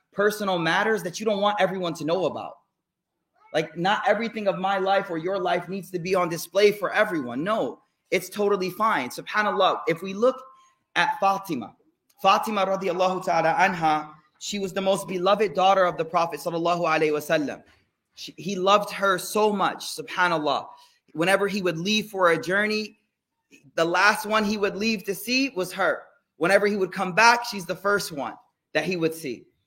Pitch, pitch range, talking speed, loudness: 195 Hz, 175-205 Hz, 180 wpm, -24 LUFS